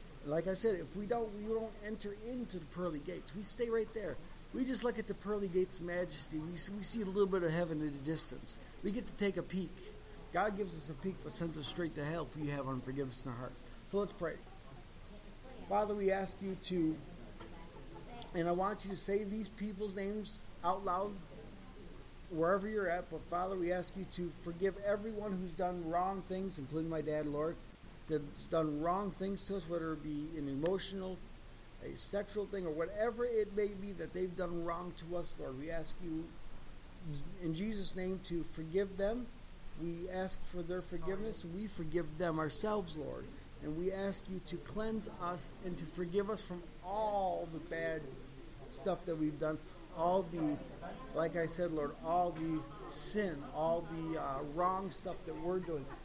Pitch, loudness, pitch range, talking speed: 180 Hz, -39 LUFS, 160-200 Hz, 195 wpm